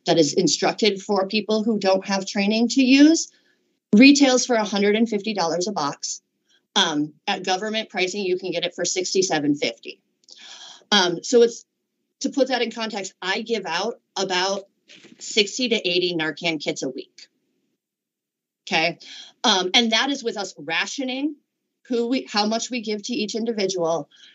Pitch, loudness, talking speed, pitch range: 210 Hz, -21 LUFS, 155 wpm, 185-235 Hz